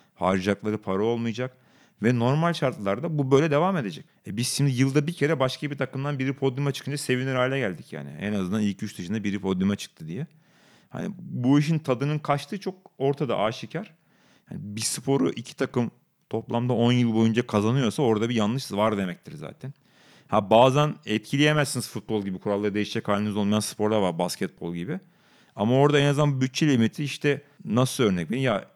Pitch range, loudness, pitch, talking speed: 105-145 Hz, -25 LUFS, 125 Hz, 175 wpm